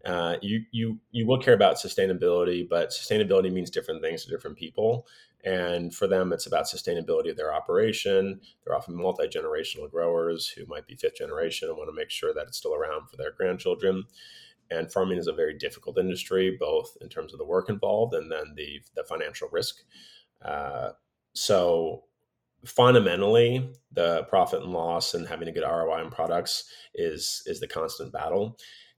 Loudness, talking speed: -27 LUFS, 180 wpm